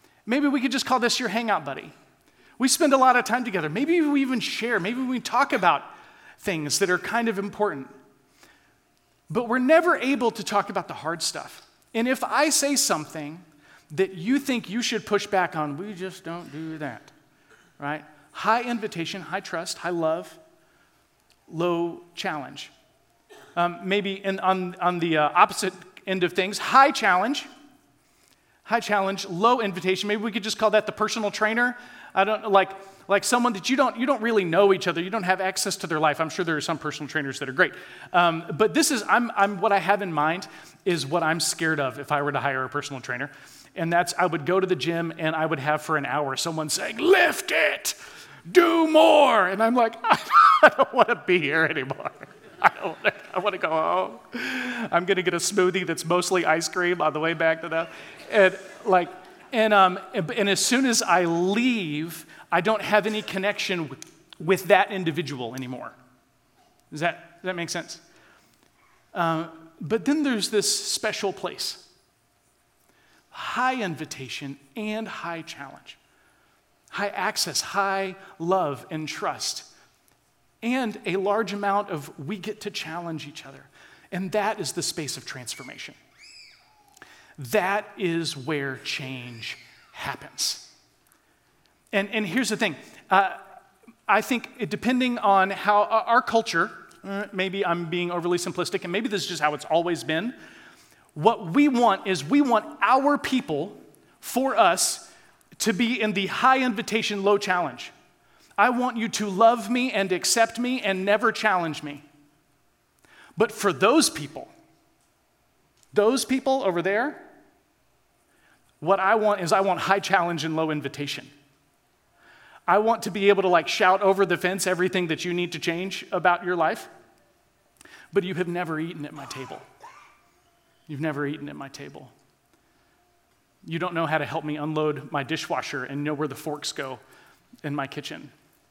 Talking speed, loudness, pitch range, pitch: 170 wpm, -24 LUFS, 165-220 Hz, 190 Hz